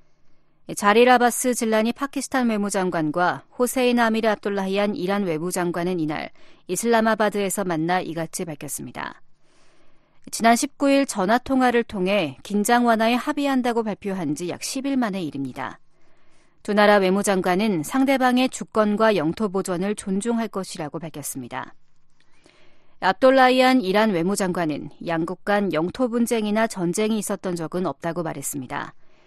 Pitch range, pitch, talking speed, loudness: 175-235 Hz, 205 Hz, 320 characters per minute, -22 LUFS